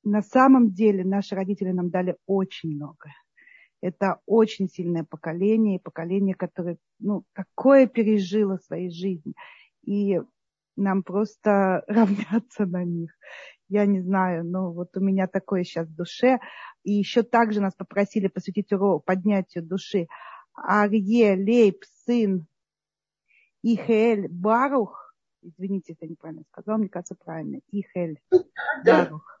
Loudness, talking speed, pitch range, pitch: -24 LUFS, 130 wpm, 180-215 Hz, 195 Hz